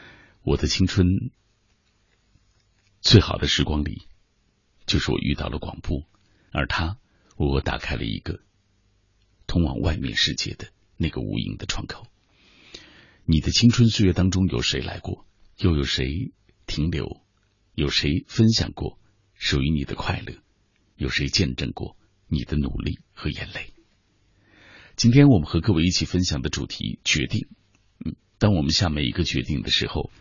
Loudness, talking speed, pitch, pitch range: -23 LUFS, 215 characters per minute, 95 Hz, 80-105 Hz